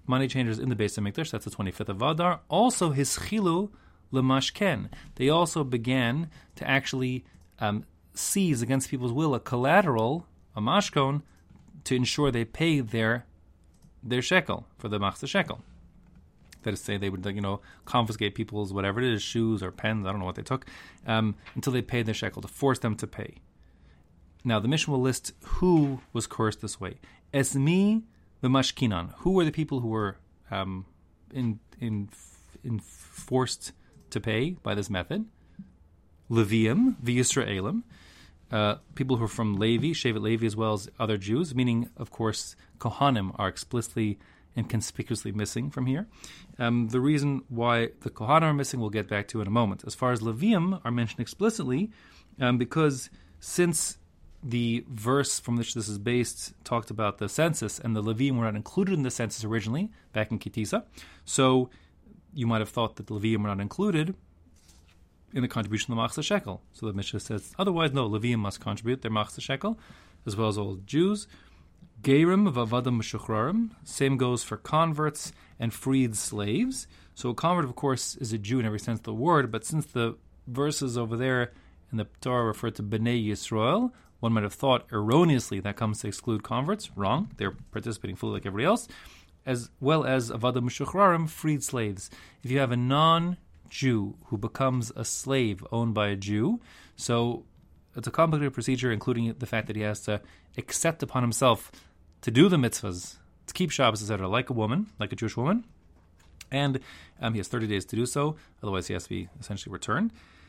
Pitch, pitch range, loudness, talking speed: 120 Hz, 105-135 Hz, -28 LUFS, 180 wpm